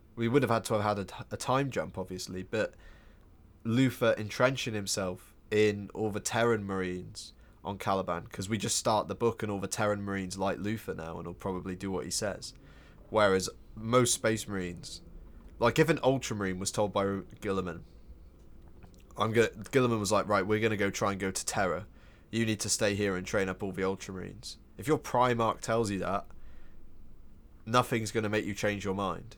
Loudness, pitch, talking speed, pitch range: -31 LUFS, 100 Hz, 200 wpm, 95-110 Hz